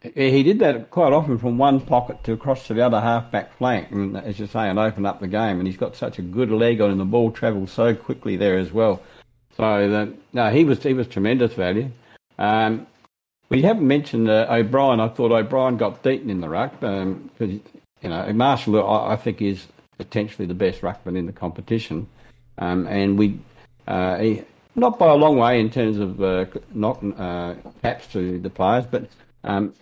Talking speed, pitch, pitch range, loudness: 205 wpm, 110 Hz, 100-120 Hz, -21 LUFS